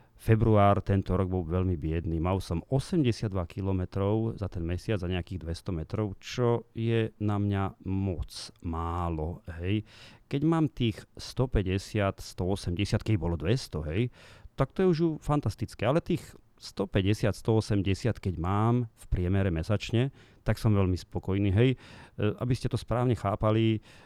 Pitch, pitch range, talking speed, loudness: 105 Hz, 95-115 Hz, 145 wpm, -29 LUFS